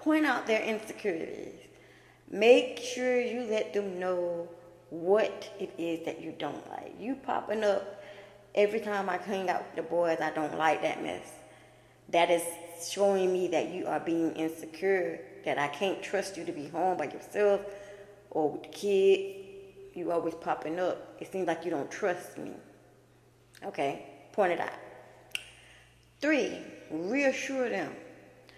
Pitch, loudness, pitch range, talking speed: 195 Hz, -31 LUFS, 170-220 Hz, 155 wpm